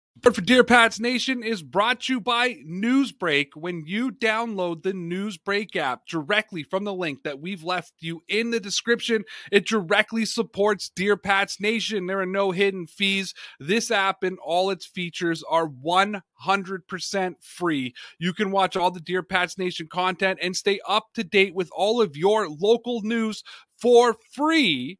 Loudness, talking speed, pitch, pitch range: -23 LUFS, 165 wpm, 195 Hz, 180-225 Hz